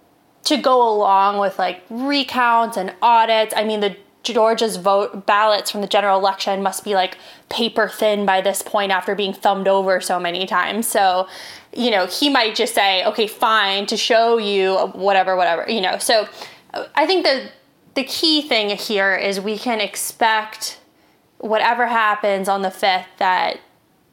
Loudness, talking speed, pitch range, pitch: -18 LUFS, 165 wpm, 195-225 Hz, 205 Hz